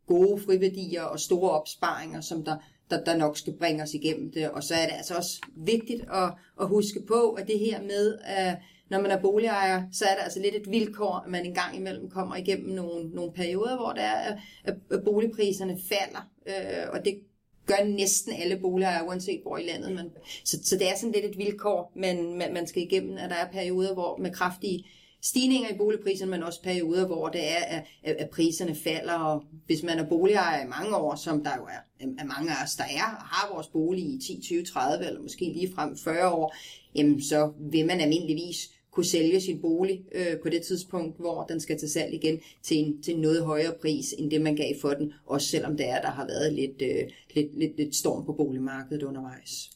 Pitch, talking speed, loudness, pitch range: 175 Hz, 205 wpm, -29 LUFS, 155-195 Hz